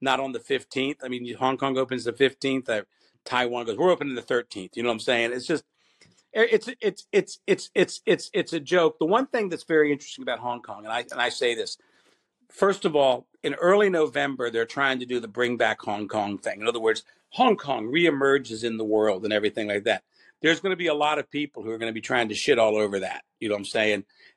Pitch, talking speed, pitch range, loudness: 130 Hz, 250 wpm, 115-155 Hz, -25 LUFS